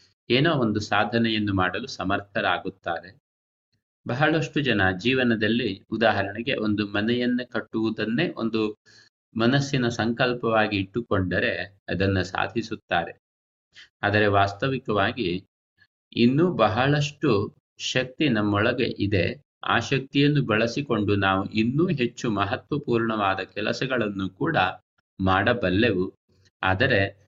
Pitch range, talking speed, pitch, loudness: 100-125 Hz, 80 wpm, 110 Hz, -24 LUFS